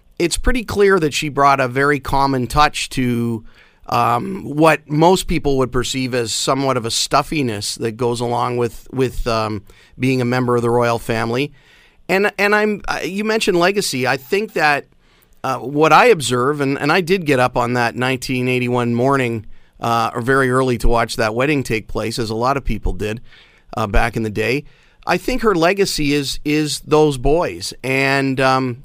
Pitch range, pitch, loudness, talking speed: 120-150 Hz, 130 Hz, -17 LUFS, 185 wpm